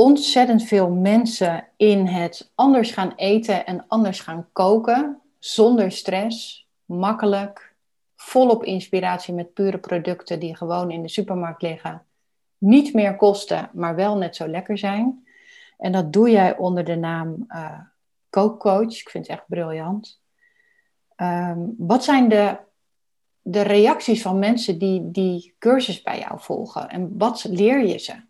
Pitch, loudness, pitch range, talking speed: 200 Hz, -20 LUFS, 180-230 Hz, 145 wpm